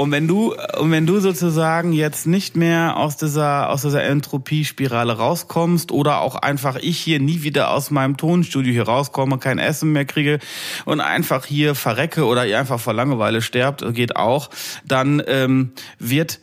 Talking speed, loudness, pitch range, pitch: 170 wpm, -19 LUFS, 135-160 Hz, 145 Hz